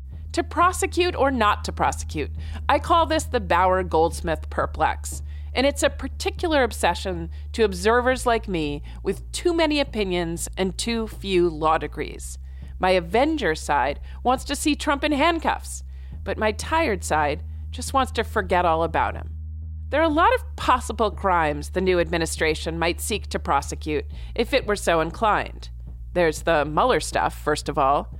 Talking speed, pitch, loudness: 165 wpm, 160 Hz, -23 LUFS